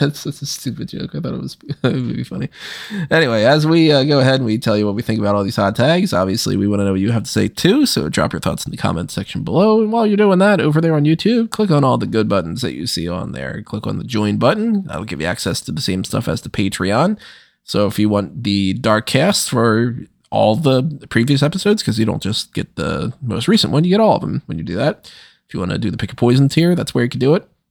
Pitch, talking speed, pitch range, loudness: 130 Hz, 285 wpm, 105-165 Hz, -17 LUFS